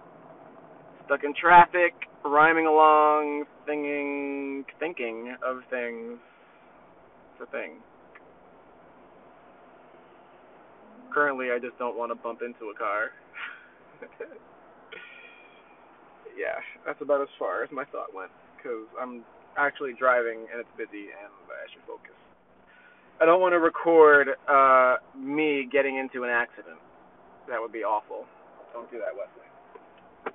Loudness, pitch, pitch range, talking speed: -24 LUFS, 140 Hz, 125-155 Hz, 120 wpm